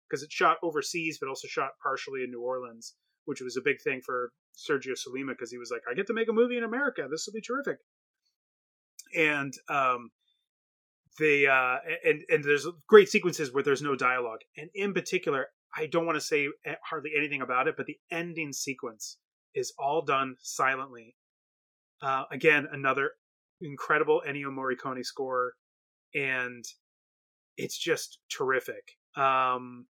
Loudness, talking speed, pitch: -29 LUFS, 160 wpm, 145 Hz